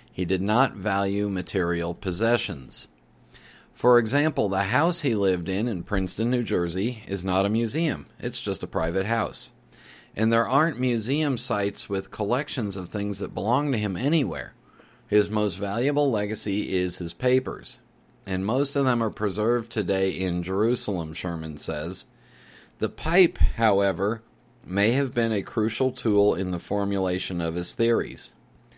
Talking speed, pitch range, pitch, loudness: 150 wpm, 95-120 Hz, 105 Hz, -25 LUFS